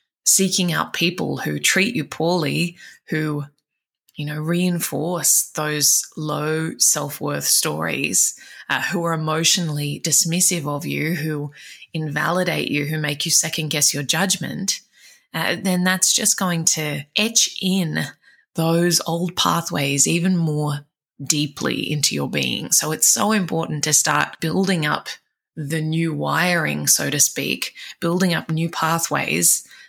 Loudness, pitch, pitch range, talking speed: -19 LUFS, 160 Hz, 150-175 Hz, 135 wpm